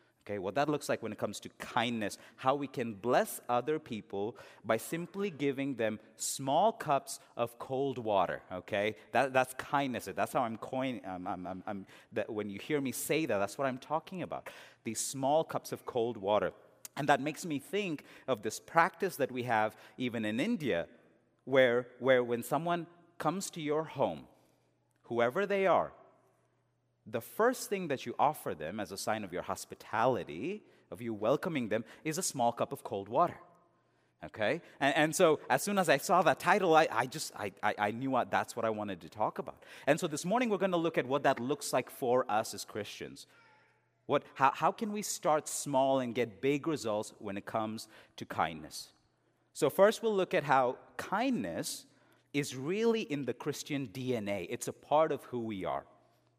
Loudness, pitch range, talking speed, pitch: -33 LUFS, 115-155 Hz, 195 wpm, 130 Hz